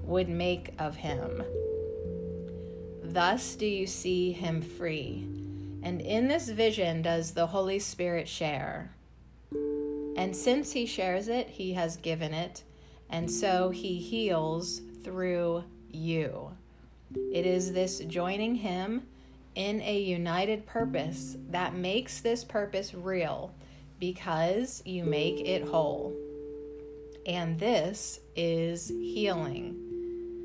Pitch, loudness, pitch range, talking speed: 175 Hz, -32 LUFS, 145-195 Hz, 110 wpm